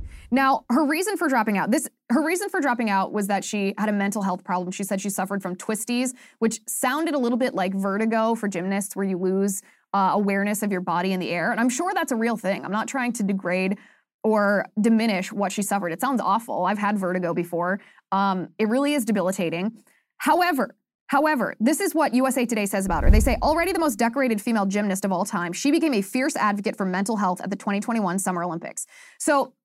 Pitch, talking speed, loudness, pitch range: 210 Hz, 225 wpm, -24 LUFS, 195-255 Hz